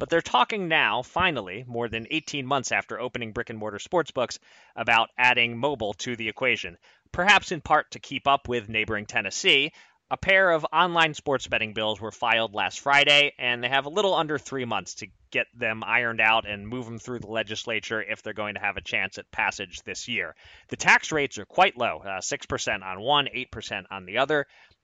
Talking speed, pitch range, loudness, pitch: 205 wpm, 110-140 Hz, -24 LUFS, 120 Hz